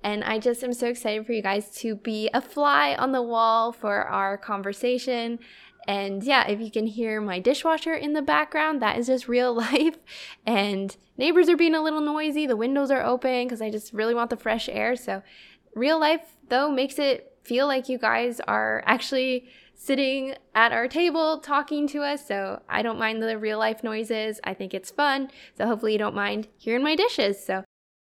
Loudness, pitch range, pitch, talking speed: -25 LUFS, 220-285 Hz, 240 Hz, 200 wpm